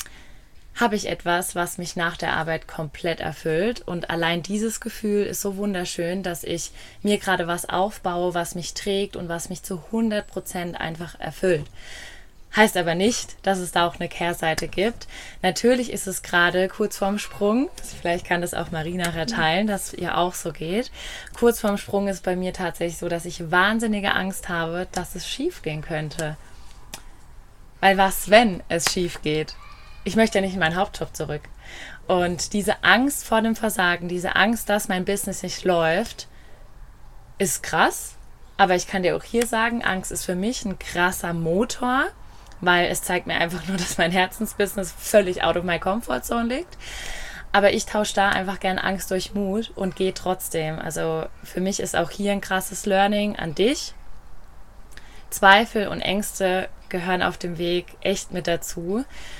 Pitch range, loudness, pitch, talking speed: 175-205 Hz, -23 LUFS, 185 Hz, 175 wpm